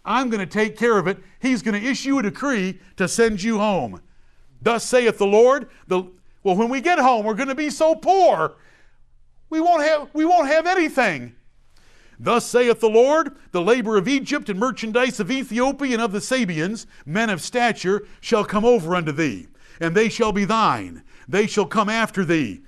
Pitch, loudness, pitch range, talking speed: 230 Hz, -20 LUFS, 205-265 Hz, 195 wpm